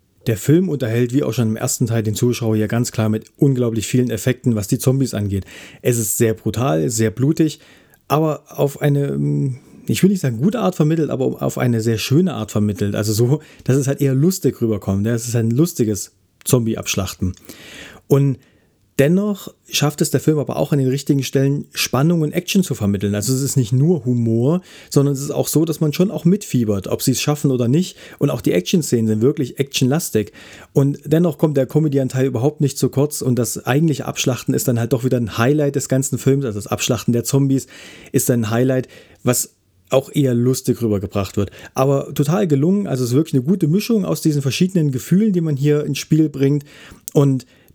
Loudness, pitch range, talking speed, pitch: -18 LUFS, 115-150 Hz, 205 wpm, 135 Hz